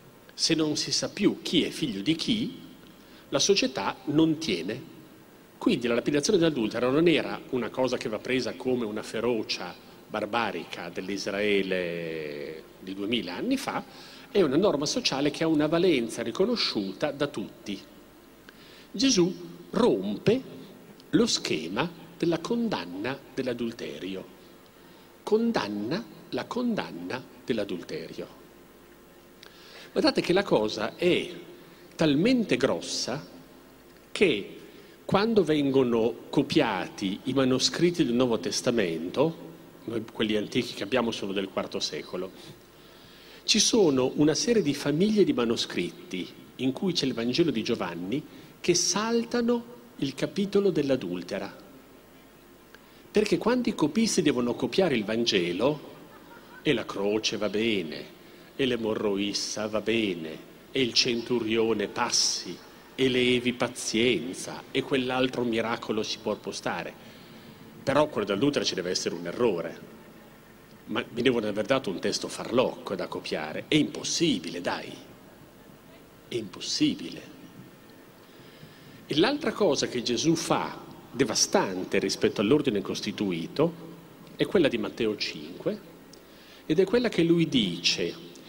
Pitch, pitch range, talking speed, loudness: 135 Hz, 115-180 Hz, 120 wpm, -27 LUFS